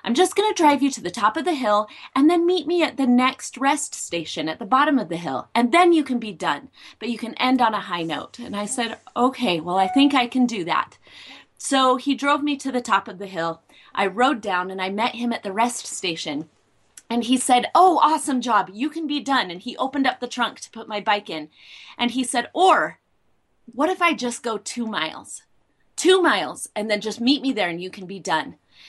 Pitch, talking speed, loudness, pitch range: 240 Hz, 245 wpm, -21 LUFS, 205-275 Hz